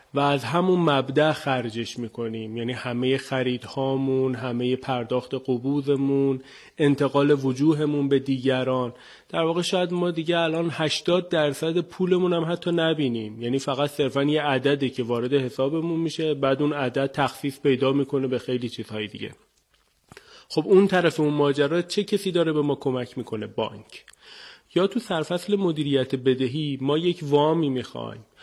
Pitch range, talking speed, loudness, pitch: 130-160 Hz, 145 wpm, -24 LUFS, 140 Hz